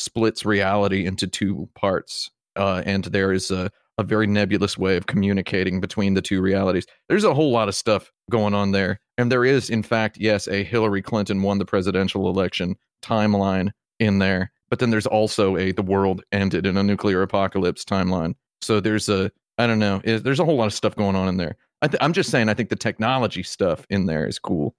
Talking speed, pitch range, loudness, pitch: 215 wpm, 95-110 Hz, -22 LUFS, 100 Hz